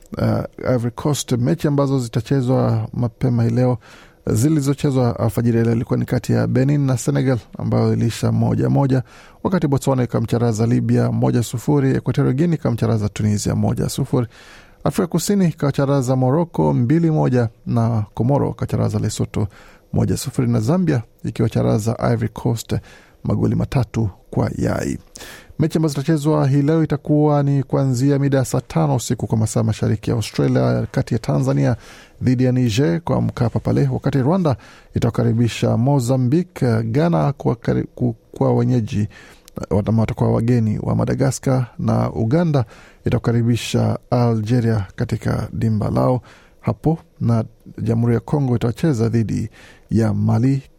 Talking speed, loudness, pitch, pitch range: 125 wpm, -19 LUFS, 125 Hz, 115-140 Hz